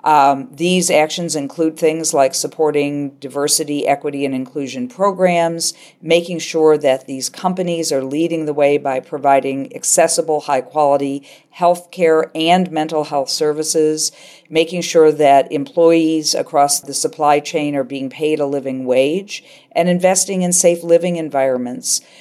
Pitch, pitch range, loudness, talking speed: 155 Hz, 140-170 Hz, -16 LUFS, 140 wpm